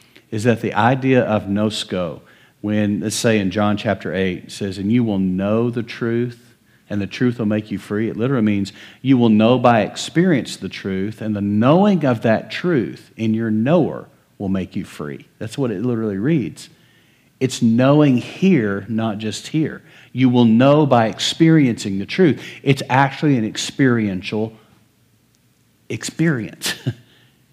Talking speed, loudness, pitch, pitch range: 160 wpm, -18 LUFS, 115 Hz, 105-130 Hz